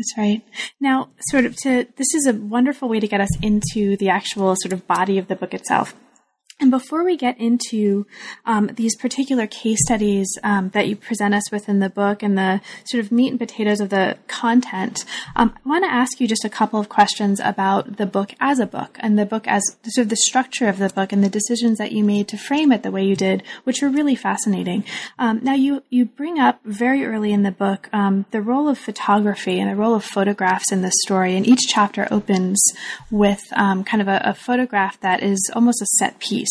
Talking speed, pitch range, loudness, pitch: 230 wpm, 200-245 Hz, -19 LUFS, 210 Hz